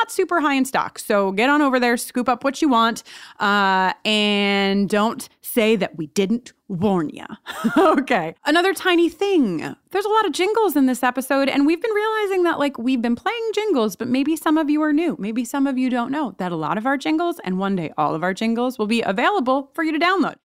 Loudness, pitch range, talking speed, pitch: -20 LUFS, 215-325 Hz, 230 wpm, 260 Hz